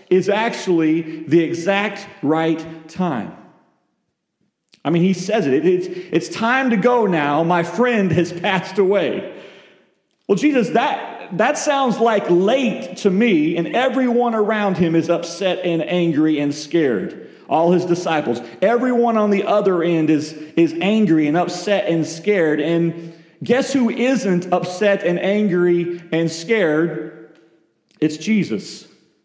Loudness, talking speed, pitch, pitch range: -18 LUFS, 135 wpm, 175 Hz, 165-210 Hz